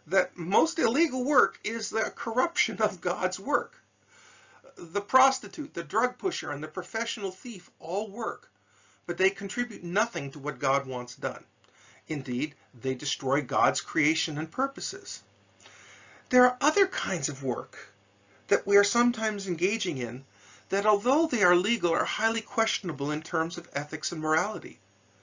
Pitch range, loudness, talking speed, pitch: 140-225 Hz, -28 LUFS, 150 wpm, 180 Hz